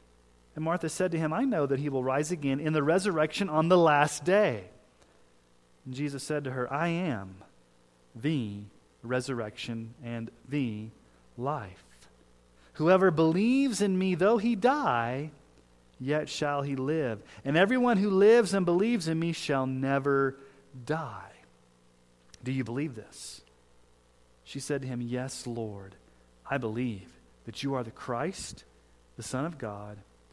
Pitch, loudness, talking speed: 130 Hz, -29 LUFS, 145 wpm